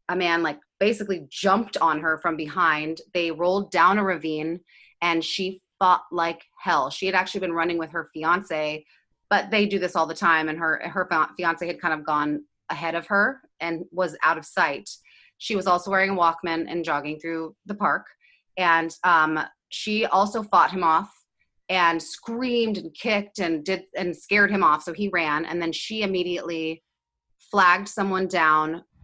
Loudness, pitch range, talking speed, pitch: -23 LUFS, 160-195 Hz, 180 wpm, 175 Hz